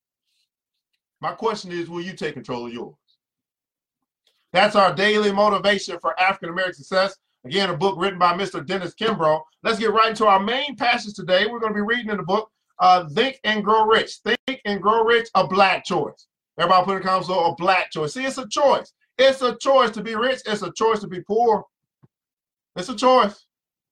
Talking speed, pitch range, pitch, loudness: 200 wpm, 185-225 Hz, 205 Hz, -20 LUFS